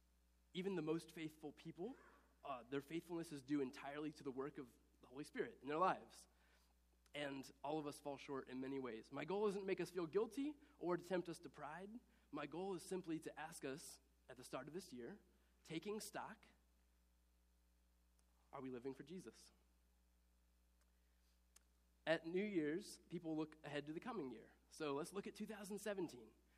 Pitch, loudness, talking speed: 145 Hz, -49 LUFS, 180 wpm